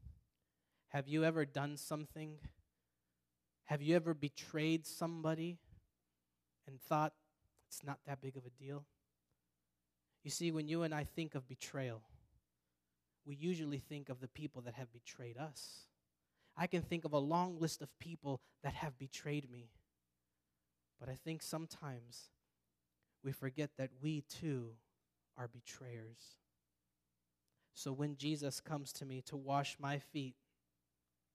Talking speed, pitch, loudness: 140 wpm, 135 Hz, -43 LUFS